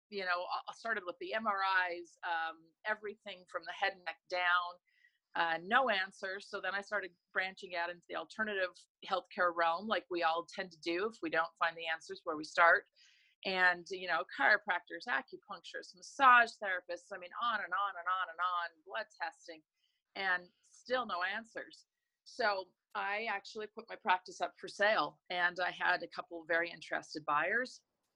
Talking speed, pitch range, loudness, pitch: 180 wpm, 175-205 Hz, -35 LUFS, 185 Hz